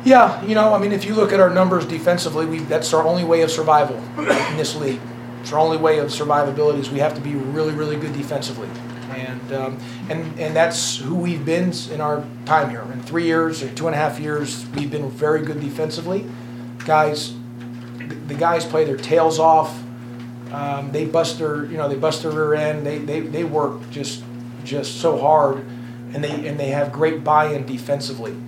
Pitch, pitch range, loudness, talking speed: 145 Hz, 125-160 Hz, -20 LUFS, 200 wpm